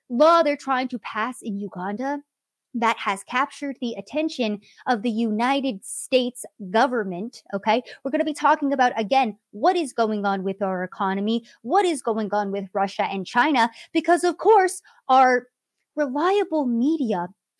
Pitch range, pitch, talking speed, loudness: 210-290 Hz, 245 Hz, 155 wpm, -23 LUFS